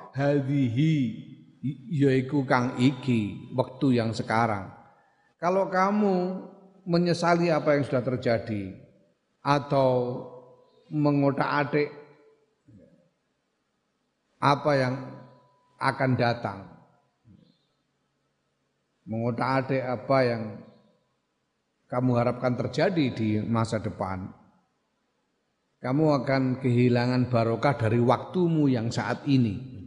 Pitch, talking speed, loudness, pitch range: 130 Hz, 80 wpm, -26 LUFS, 120-145 Hz